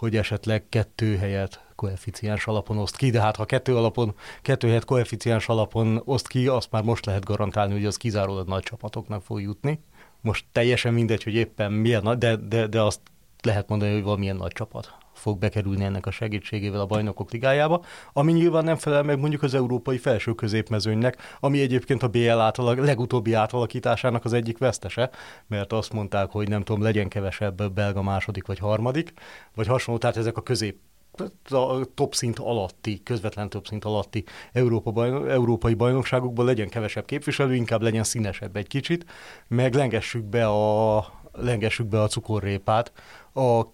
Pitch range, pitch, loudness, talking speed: 105-125 Hz, 115 Hz, -25 LUFS, 170 wpm